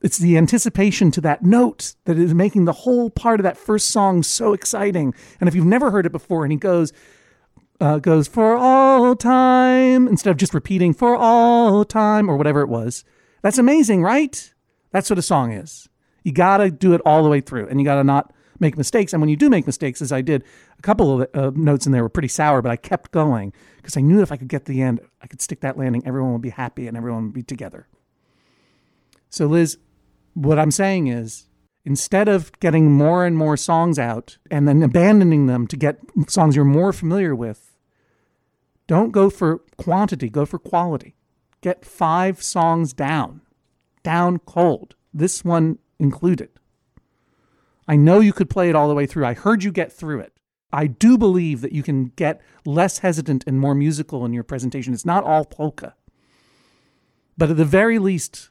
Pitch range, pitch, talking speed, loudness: 140-190 Hz, 160 Hz, 200 wpm, -18 LUFS